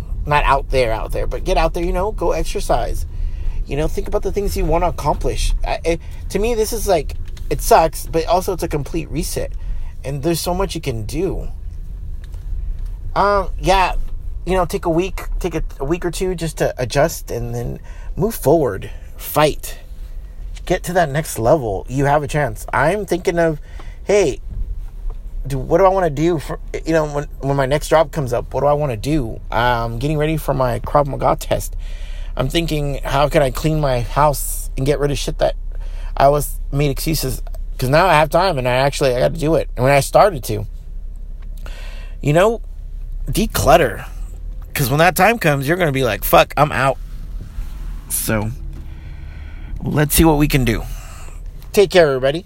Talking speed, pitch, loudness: 195 wpm, 135 Hz, -18 LUFS